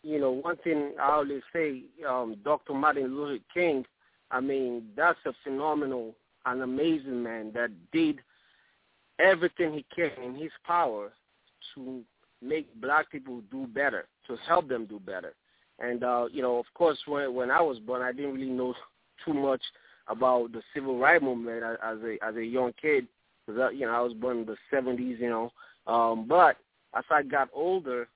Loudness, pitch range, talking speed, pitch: -29 LUFS, 120-150 Hz, 180 wpm, 130 Hz